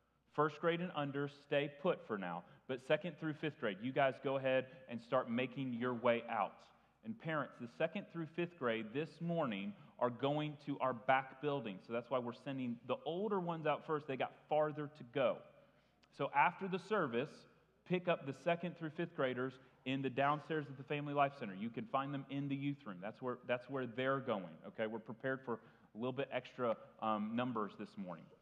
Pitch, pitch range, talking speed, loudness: 140 Hz, 130-155 Hz, 205 wpm, -40 LUFS